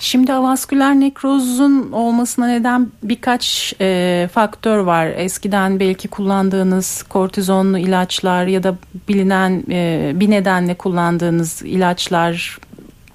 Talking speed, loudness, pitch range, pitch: 100 wpm, -16 LUFS, 180-240 Hz, 195 Hz